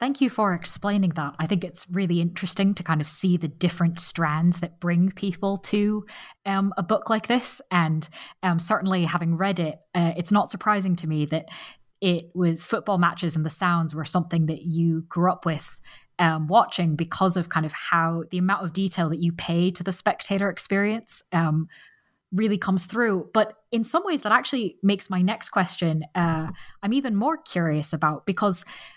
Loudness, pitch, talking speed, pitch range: -24 LUFS, 180 Hz, 190 wpm, 165-205 Hz